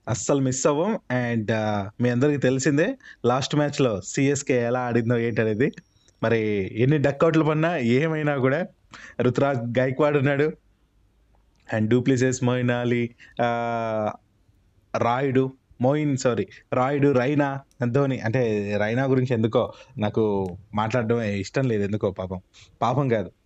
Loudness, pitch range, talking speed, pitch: -23 LUFS, 110-140 Hz, 110 wpm, 125 Hz